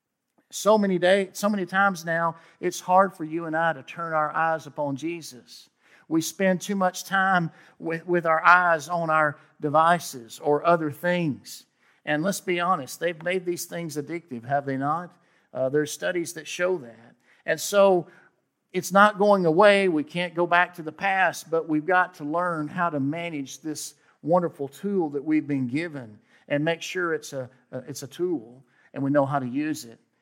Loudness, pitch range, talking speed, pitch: -24 LUFS, 145-180 Hz, 190 wpm, 165 Hz